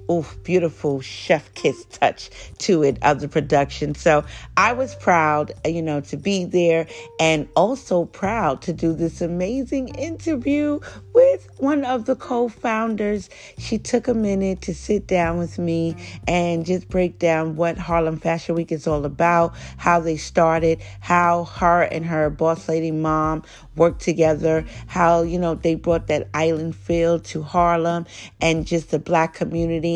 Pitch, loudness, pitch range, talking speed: 170 Hz, -21 LUFS, 160-180 Hz, 160 wpm